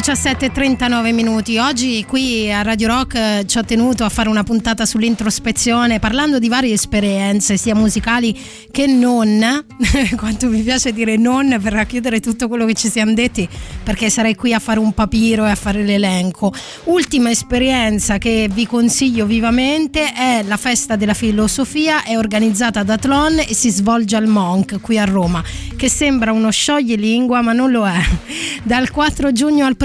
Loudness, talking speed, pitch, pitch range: -15 LUFS, 165 wpm, 230 Hz, 215-255 Hz